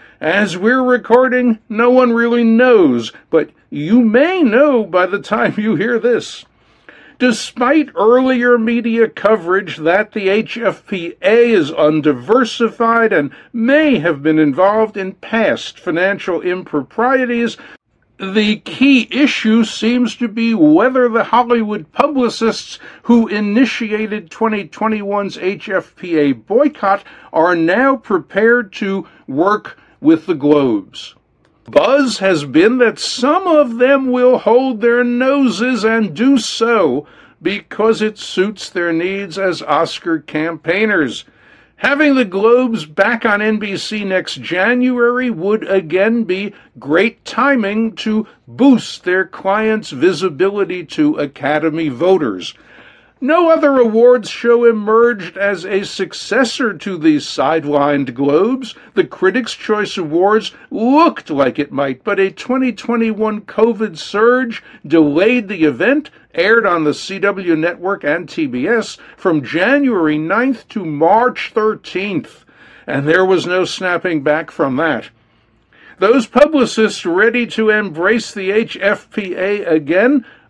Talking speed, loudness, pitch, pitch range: 120 wpm, -14 LUFS, 220 Hz, 185-245 Hz